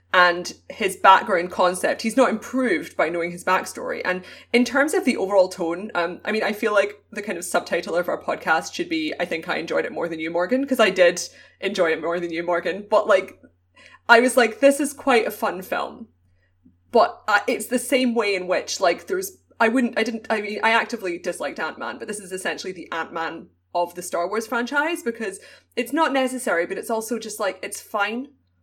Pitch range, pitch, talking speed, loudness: 175-245 Hz, 215 Hz, 220 wpm, -22 LUFS